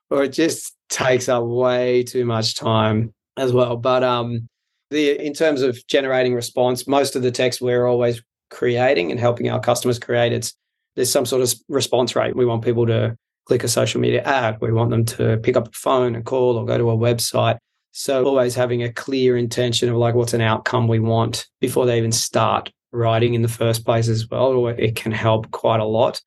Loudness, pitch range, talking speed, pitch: -19 LUFS, 115-125 Hz, 210 wpm, 120 Hz